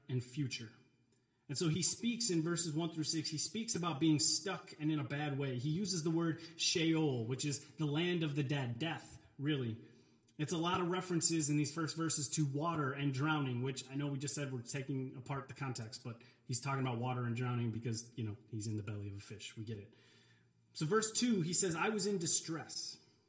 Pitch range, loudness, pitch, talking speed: 125-165 Hz, -37 LUFS, 145 Hz, 225 wpm